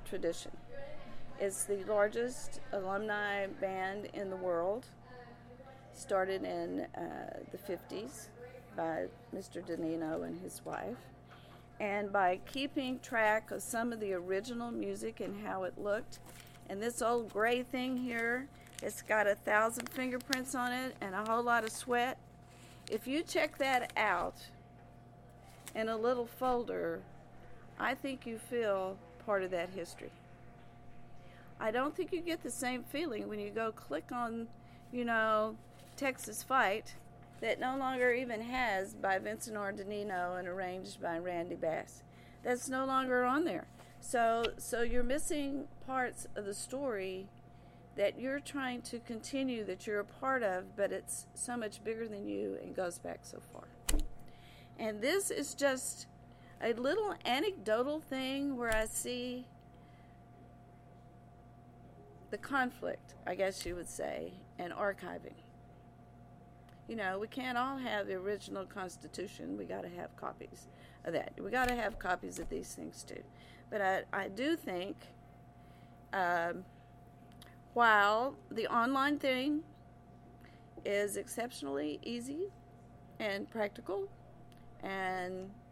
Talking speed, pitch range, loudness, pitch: 135 wpm, 185-250 Hz, -37 LUFS, 215 Hz